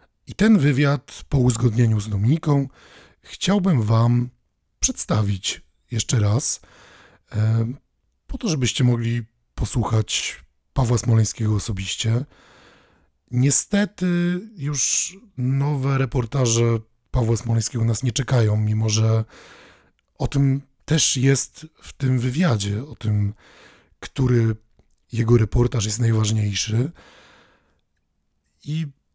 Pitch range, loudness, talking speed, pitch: 110-135 Hz, -21 LUFS, 95 wpm, 120 Hz